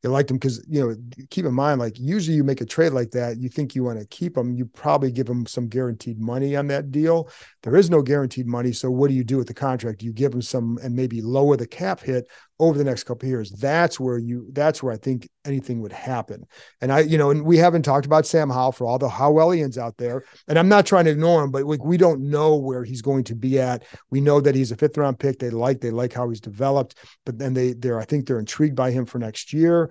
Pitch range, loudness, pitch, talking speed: 125-145 Hz, -21 LUFS, 130 Hz, 275 wpm